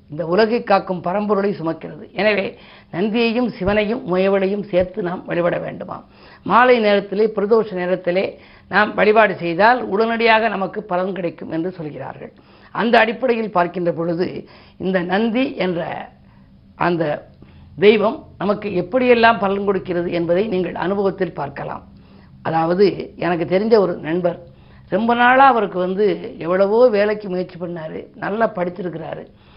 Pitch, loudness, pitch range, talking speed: 195 Hz, -18 LUFS, 175-220 Hz, 120 wpm